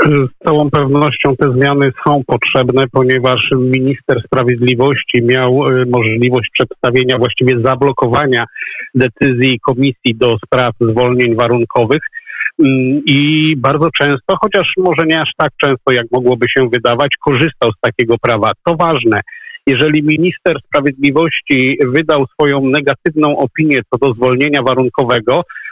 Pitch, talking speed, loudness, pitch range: 135 Hz, 120 wpm, -12 LUFS, 125-150 Hz